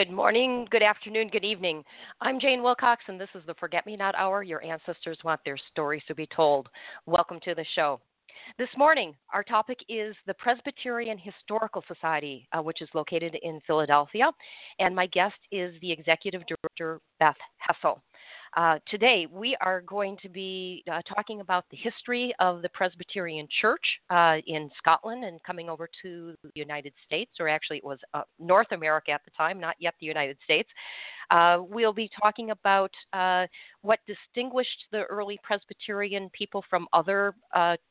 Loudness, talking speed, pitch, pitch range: -27 LUFS, 175 wpm, 185 Hz, 165-210 Hz